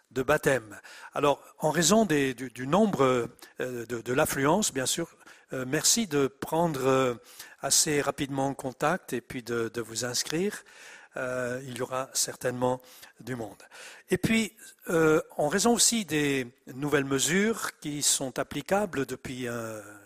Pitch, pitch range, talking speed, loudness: 135 Hz, 125-165 Hz, 155 wpm, -27 LUFS